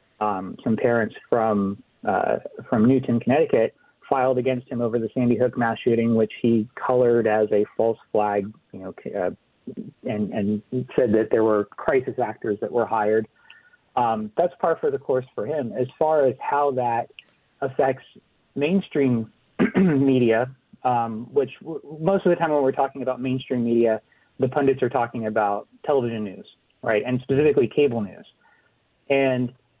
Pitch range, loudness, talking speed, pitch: 110-135 Hz, -23 LUFS, 160 wpm, 125 Hz